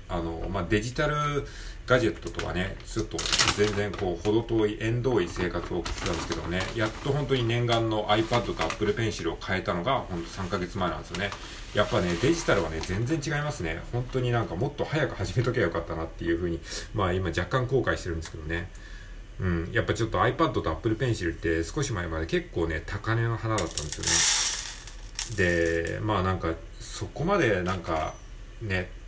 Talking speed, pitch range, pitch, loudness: 425 characters per minute, 85-115 Hz, 100 Hz, -27 LUFS